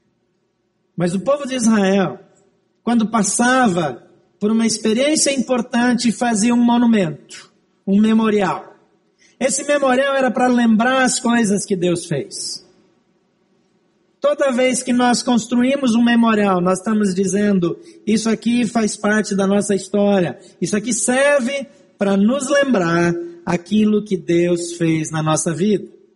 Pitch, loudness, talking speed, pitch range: 205 Hz, -17 LUFS, 130 wpm, 185-240 Hz